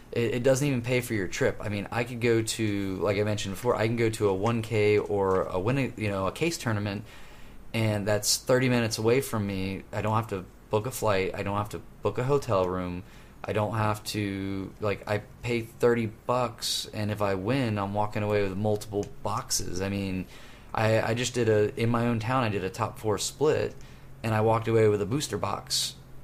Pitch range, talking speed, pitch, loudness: 100-115 Hz, 220 wpm, 105 Hz, -28 LUFS